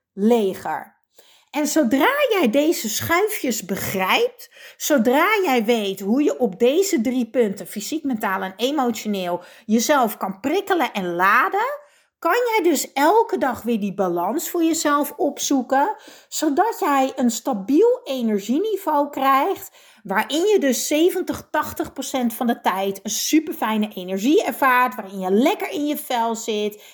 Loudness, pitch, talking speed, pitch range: -20 LUFS, 265 Hz, 140 wpm, 220-315 Hz